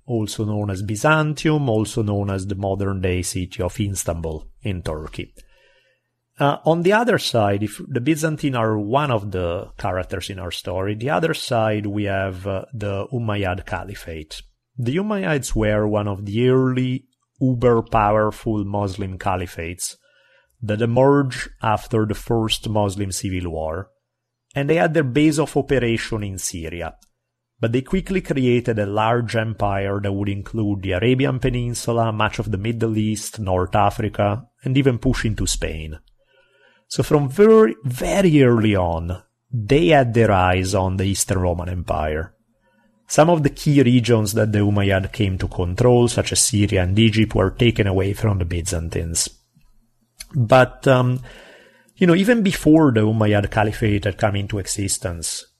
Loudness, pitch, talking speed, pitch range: -20 LUFS, 110 Hz, 155 wpm, 100-130 Hz